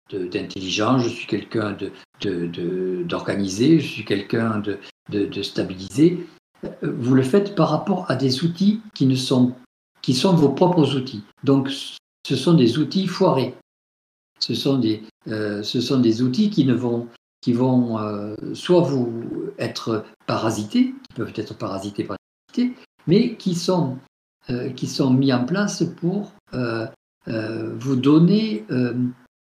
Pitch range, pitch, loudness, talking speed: 115-170 Hz, 130 Hz, -22 LUFS, 155 wpm